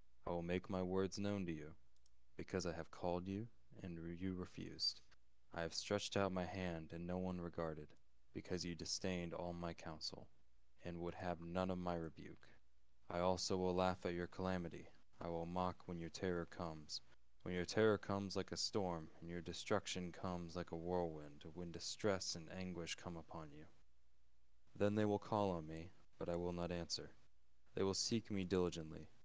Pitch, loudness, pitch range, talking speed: 85 Hz, -44 LUFS, 80-95 Hz, 185 wpm